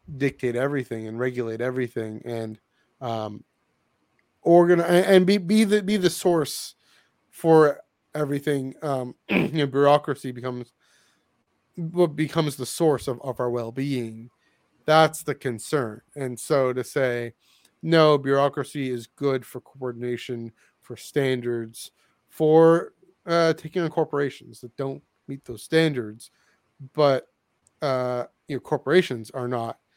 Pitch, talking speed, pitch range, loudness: 135 Hz, 125 wpm, 125-155 Hz, -23 LUFS